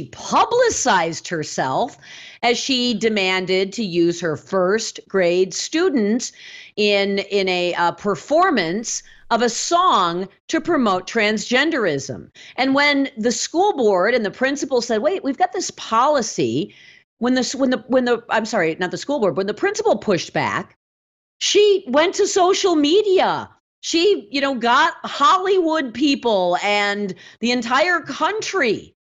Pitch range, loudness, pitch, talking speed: 200-325 Hz, -19 LUFS, 245 Hz, 140 wpm